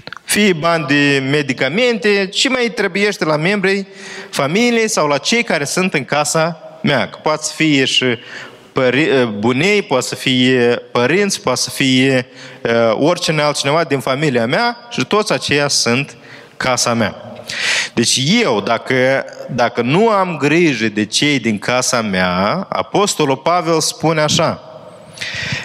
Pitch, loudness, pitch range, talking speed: 145 Hz, -15 LUFS, 125-185 Hz, 135 wpm